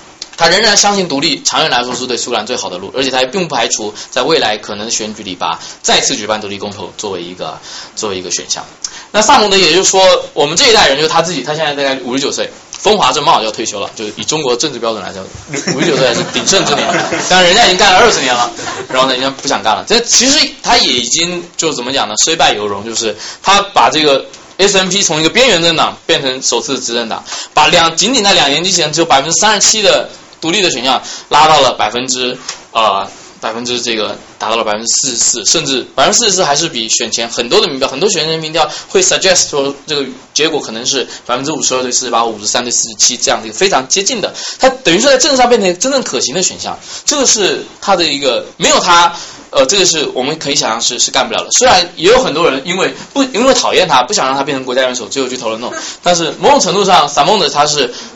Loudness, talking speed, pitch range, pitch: -11 LUFS, 385 characters per minute, 125-190 Hz, 150 Hz